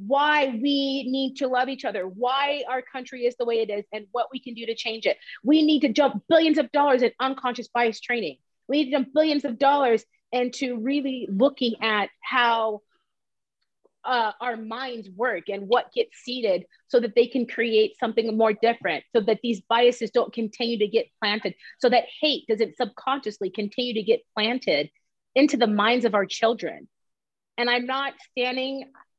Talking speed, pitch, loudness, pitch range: 185 wpm, 245 Hz, -24 LUFS, 225-270 Hz